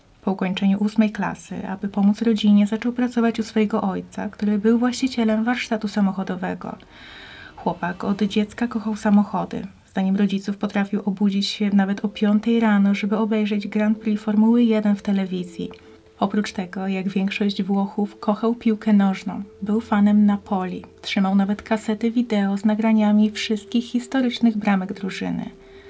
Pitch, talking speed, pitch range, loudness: 210 Hz, 140 wpm, 200-220 Hz, -21 LUFS